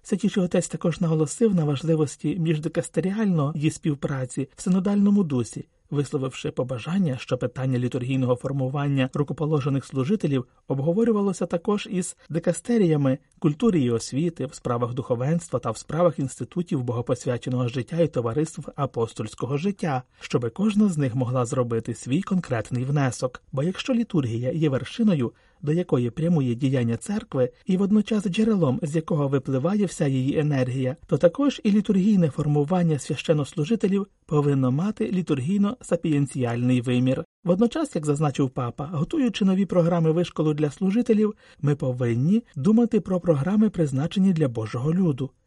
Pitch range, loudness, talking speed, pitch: 130-185 Hz, -24 LUFS, 130 wpm, 155 Hz